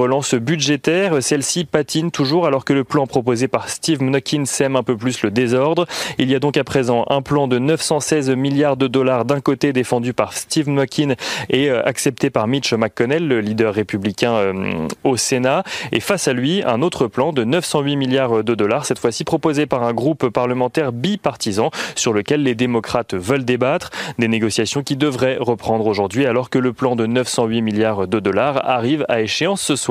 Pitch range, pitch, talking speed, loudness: 120-145 Hz, 130 Hz, 190 wpm, -18 LUFS